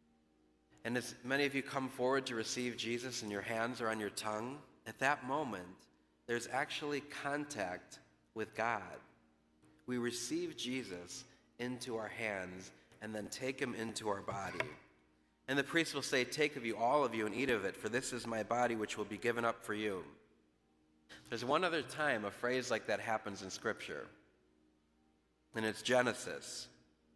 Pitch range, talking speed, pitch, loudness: 80-125 Hz, 175 wpm, 110 Hz, -39 LUFS